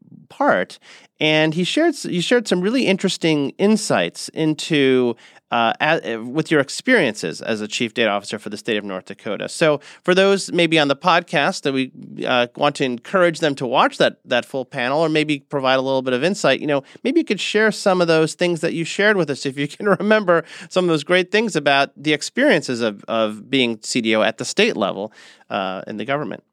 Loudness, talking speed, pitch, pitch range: -19 LUFS, 215 wpm, 155 Hz, 130-180 Hz